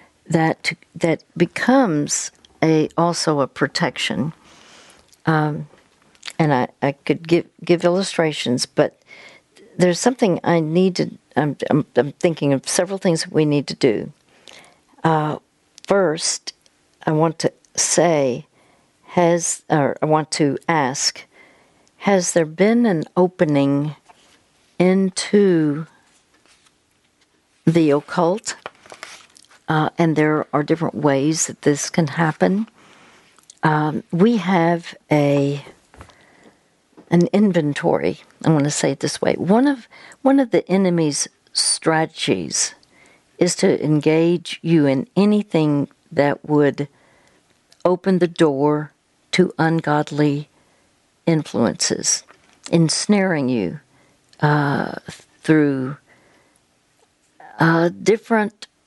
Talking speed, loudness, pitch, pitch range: 105 wpm, -19 LUFS, 160 Hz, 150-180 Hz